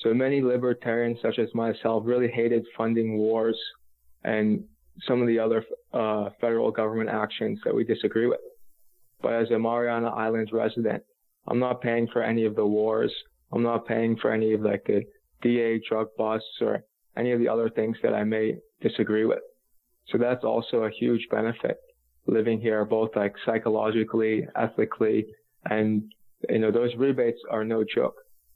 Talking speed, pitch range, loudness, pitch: 165 wpm, 110-120 Hz, -26 LUFS, 115 Hz